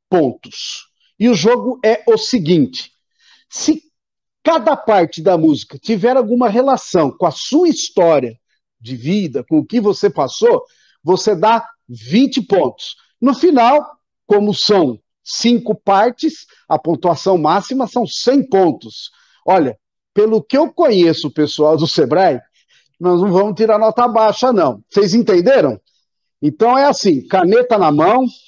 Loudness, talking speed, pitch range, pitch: -14 LUFS, 140 wpm, 185-260 Hz, 225 Hz